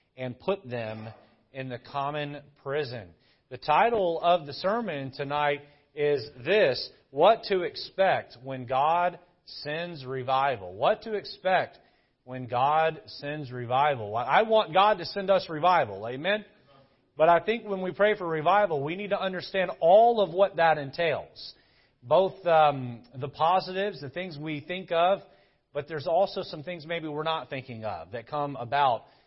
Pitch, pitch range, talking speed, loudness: 155 Hz, 135-185 Hz, 155 wpm, -27 LUFS